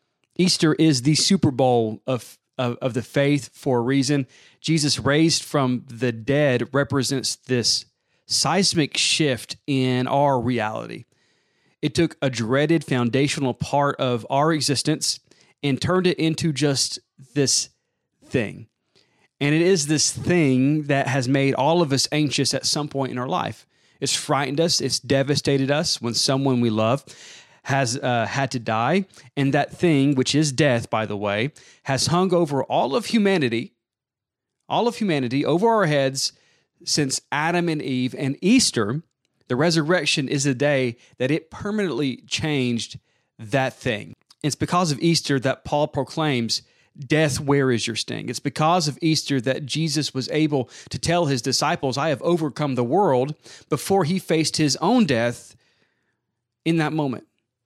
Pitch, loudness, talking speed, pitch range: 140 Hz, -22 LUFS, 155 wpm, 125-155 Hz